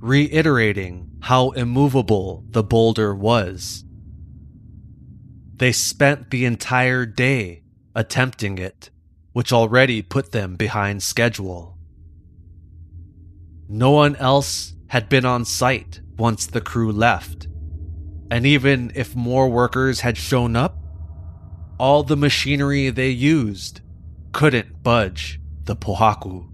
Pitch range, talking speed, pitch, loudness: 85-125 Hz, 105 wpm, 110 Hz, -19 LUFS